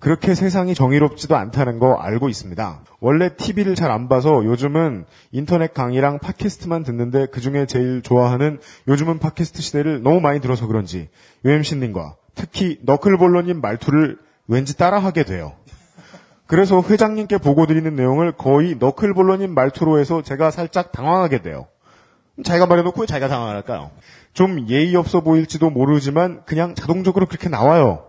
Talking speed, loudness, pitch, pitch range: 380 characters per minute, -18 LUFS, 155 Hz, 130-175 Hz